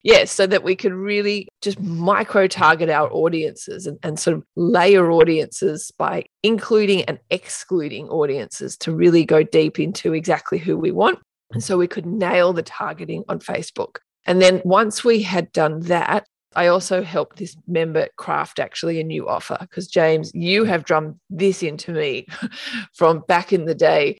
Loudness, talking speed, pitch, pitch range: -19 LUFS, 175 wpm, 180 Hz, 165-200 Hz